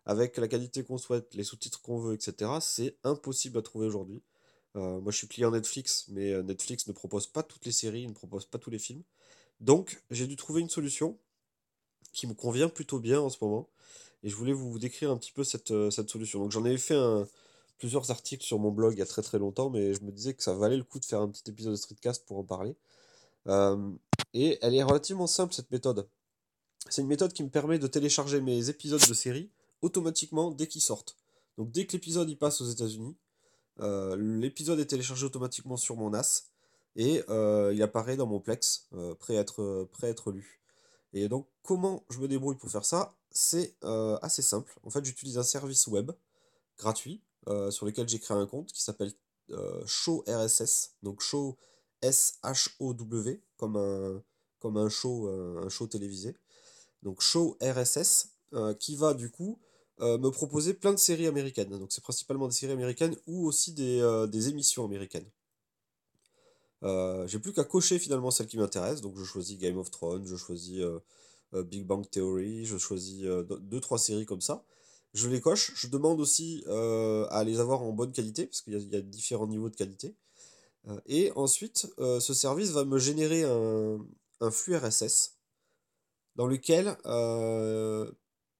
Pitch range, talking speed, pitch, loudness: 105-140 Hz, 195 wpm, 120 Hz, -31 LUFS